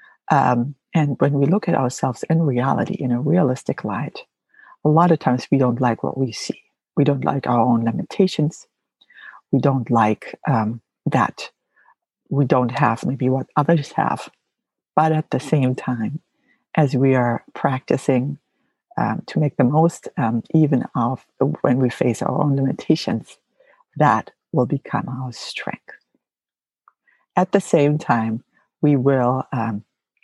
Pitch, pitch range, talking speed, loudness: 135 Hz, 125-155 Hz, 150 wpm, -20 LUFS